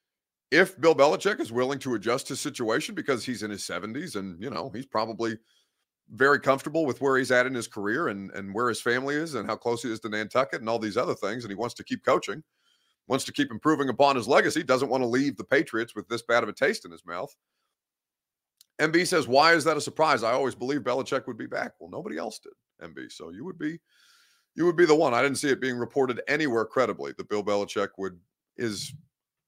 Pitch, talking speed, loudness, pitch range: 125 Hz, 235 wpm, -26 LUFS, 115-145 Hz